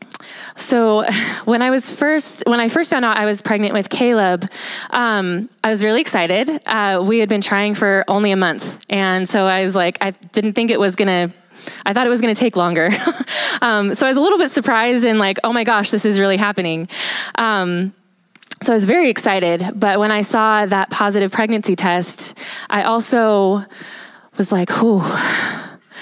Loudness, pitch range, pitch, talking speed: -16 LUFS, 195-230 Hz, 210 Hz, 190 wpm